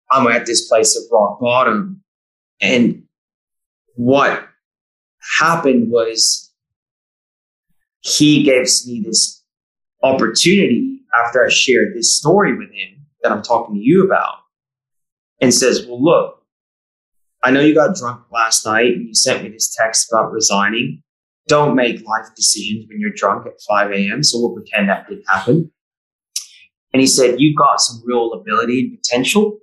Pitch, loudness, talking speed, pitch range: 130 Hz, -14 LUFS, 150 wpm, 115-170 Hz